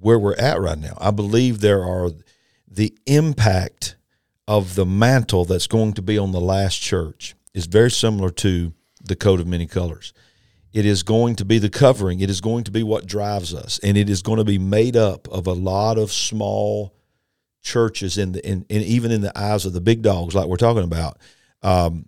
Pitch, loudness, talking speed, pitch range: 100 Hz, -19 LUFS, 210 wpm, 95-110 Hz